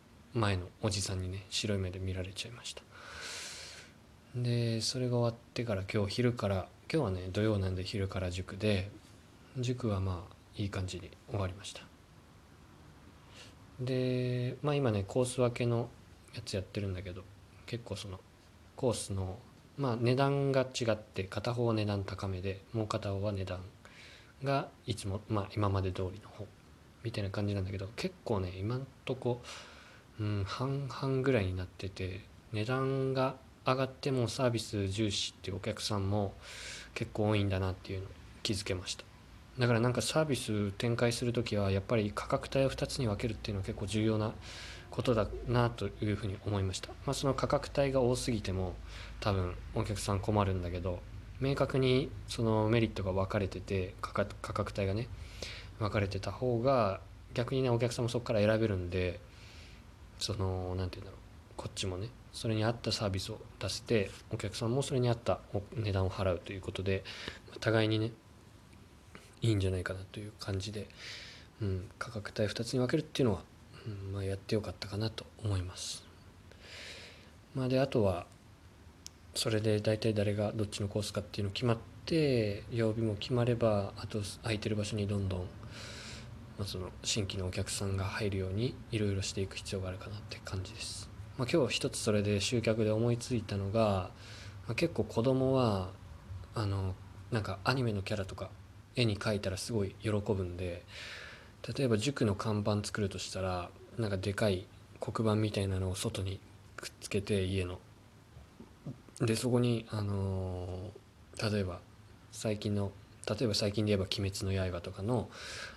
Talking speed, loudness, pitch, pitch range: 325 characters per minute, -35 LUFS, 105 Hz, 95-115 Hz